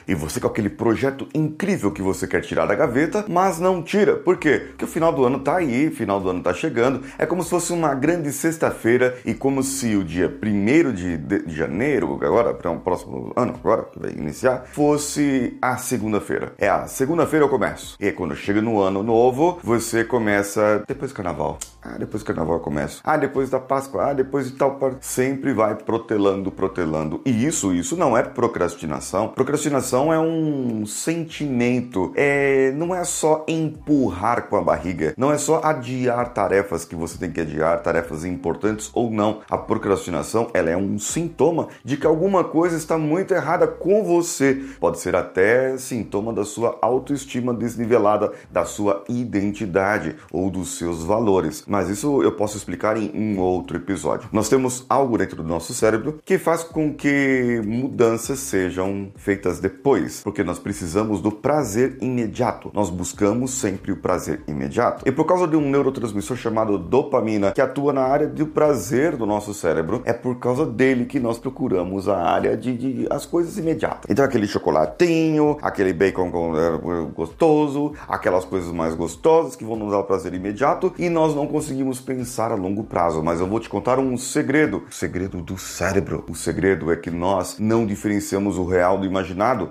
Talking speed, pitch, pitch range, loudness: 180 wpm, 120 Hz, 95-145 Hz, -21 LUFS